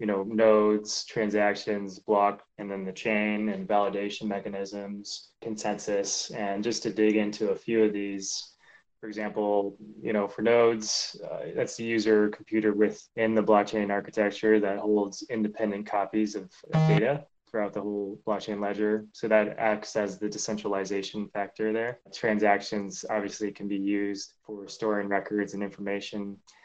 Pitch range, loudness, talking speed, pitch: 100-110 Hz, -28 LUFS, 150 wpm, 105 Hz